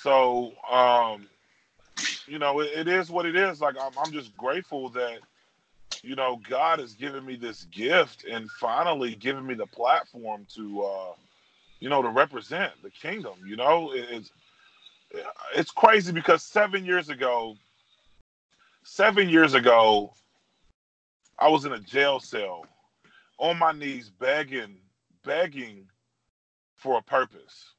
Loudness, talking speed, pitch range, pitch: -25 LUFS, 140 wpm, 110-160 Hz, 130 Hz